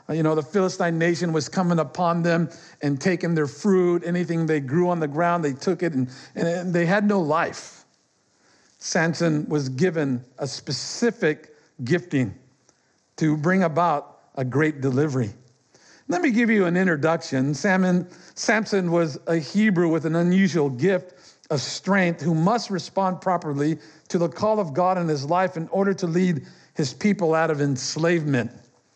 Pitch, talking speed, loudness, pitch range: 170 Hz, 160 wpm, -23 LUFS, 150-180 Hz